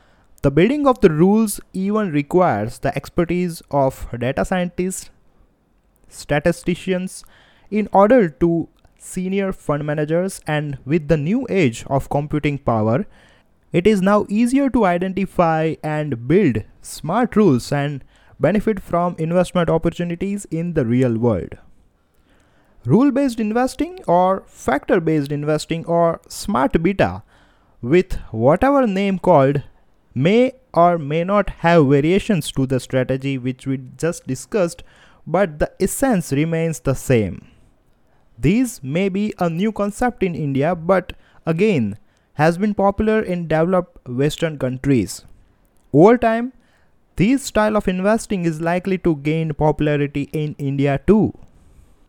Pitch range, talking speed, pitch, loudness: 140-195 Hz, 125 wpm, 170 Hz, -19 LUFS